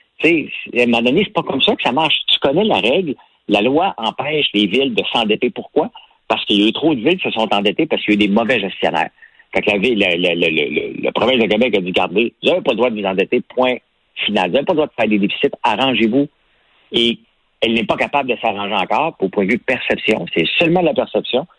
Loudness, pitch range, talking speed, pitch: -16 LUFS, 105-135 Hz, 270 wpm, 115 Hz